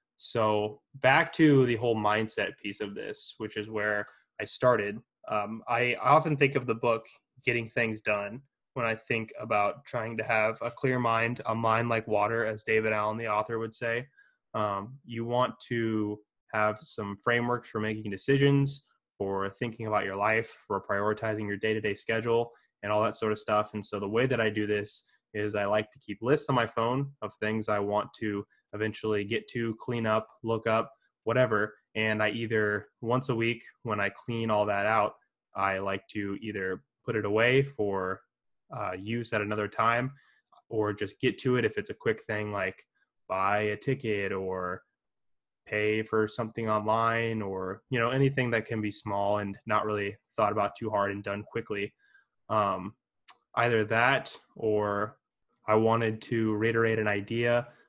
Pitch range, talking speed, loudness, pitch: 105-115 Hz, 180 wpm, -29 LUFS, 110 Hz